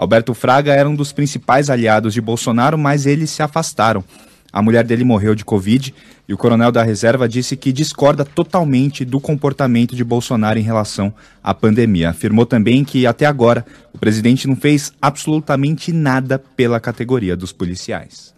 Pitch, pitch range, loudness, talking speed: 125 Hz, 110-140 Hz, -15 LUFS, 165 wpm